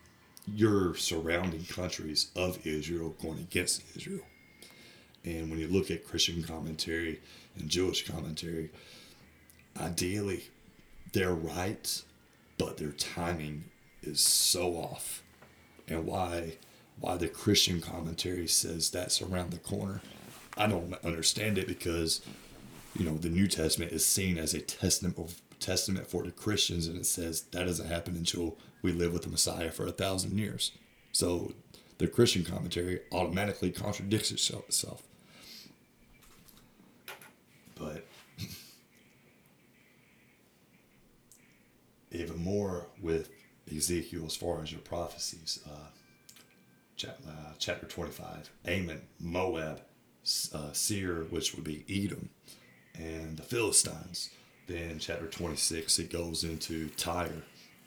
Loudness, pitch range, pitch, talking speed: -33 LUFS, 80-90 Hz, 85 Hz, 115 wpm